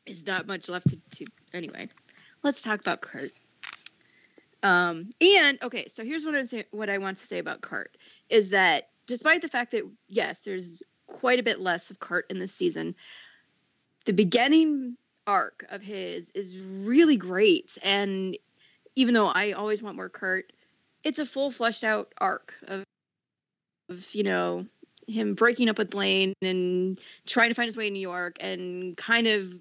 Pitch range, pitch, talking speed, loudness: 190-245 Hz, 210 Hz, 175 wpm, -26 LUFS